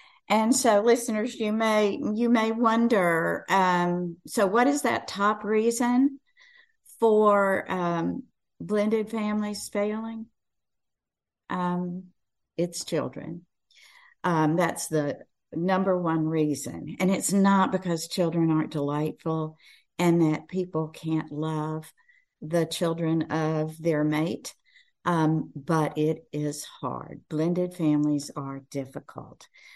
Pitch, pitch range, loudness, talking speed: 180 Hz, 155-220 Hz, -26 LUFS, 110 wpm